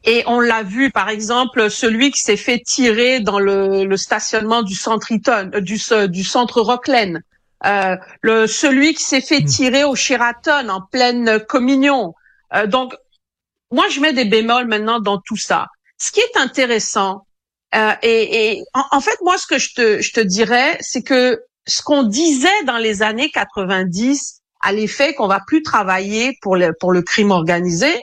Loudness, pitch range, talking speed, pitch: -15 LUFS, 205-270 Hz, 180 wpm, 235 Hz